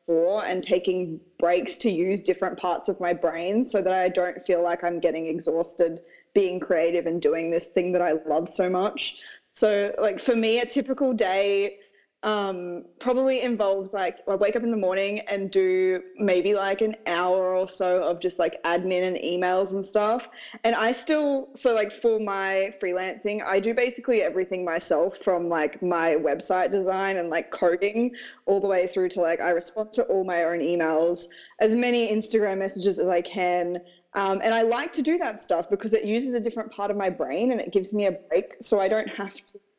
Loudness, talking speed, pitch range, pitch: -25 LUFS, 200 wpm, 175-220 Hz, 195 Hz